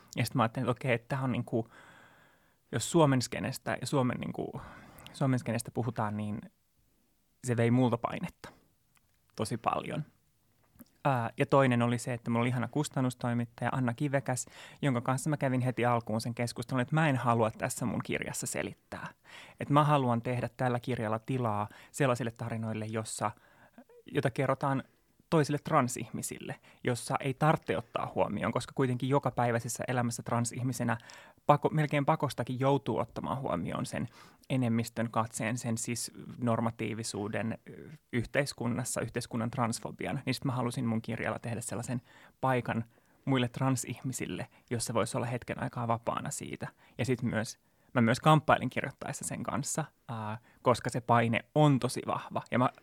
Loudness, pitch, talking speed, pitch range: -32 LUFS, 120 Hz, 140 wpm, 115-135 Hz